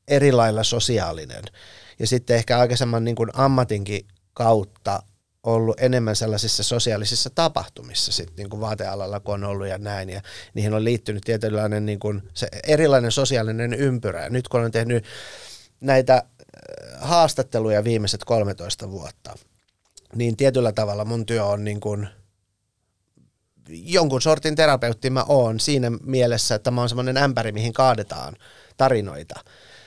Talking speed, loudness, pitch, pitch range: 135 wpm, -21 LUFS, 115 Hz, 105-125 Hz